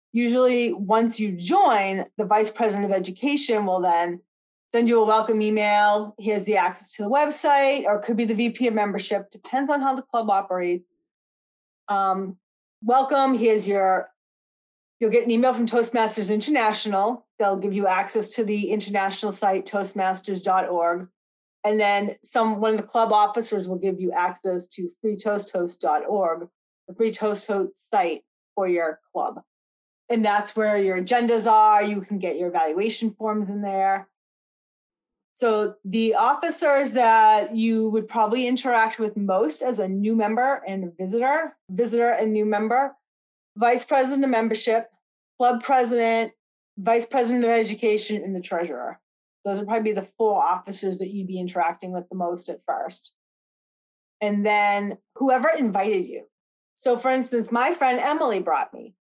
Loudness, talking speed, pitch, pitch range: -23 LUFS, 155 wpm, 215 Hz, 195-235 Hz